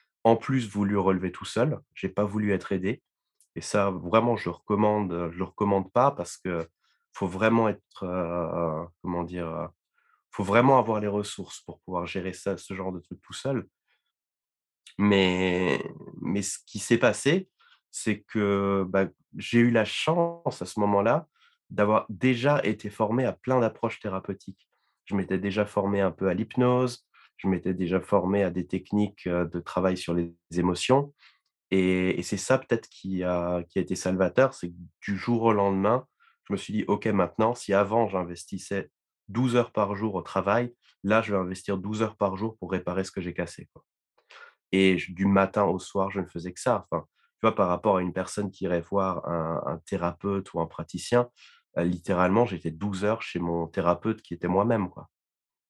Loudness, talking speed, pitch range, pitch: -27 LUFS, 185 wpm, 90-110 Hz, 100 Hz